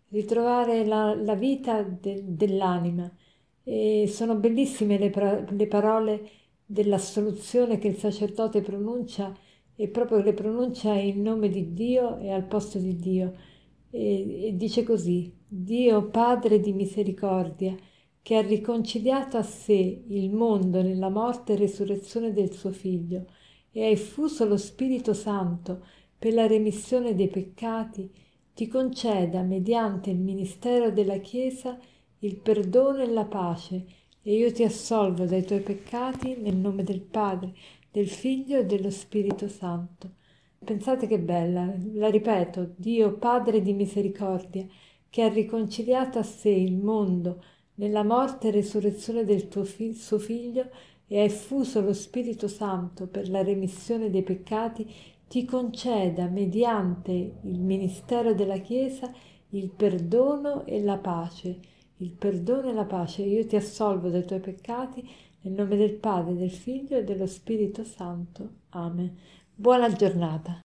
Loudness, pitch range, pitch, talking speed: -27 LUFS, 190-225 Hz, 205 Hz, 140 wpm